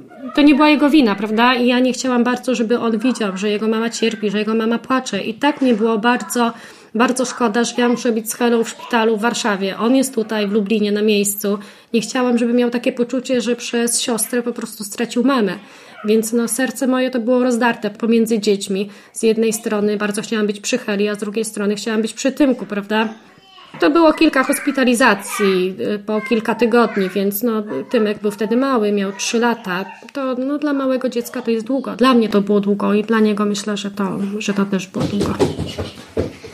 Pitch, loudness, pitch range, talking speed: 230 Hz, -17 LUFS, 210-245 Hz, 205 wpm